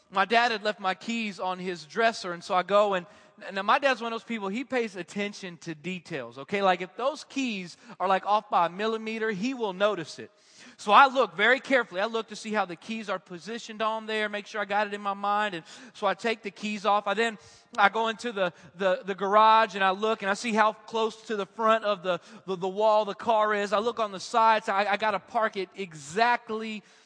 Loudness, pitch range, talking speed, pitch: -27 LUFS, 195-225 Hz, 250 wpm, 210 Hz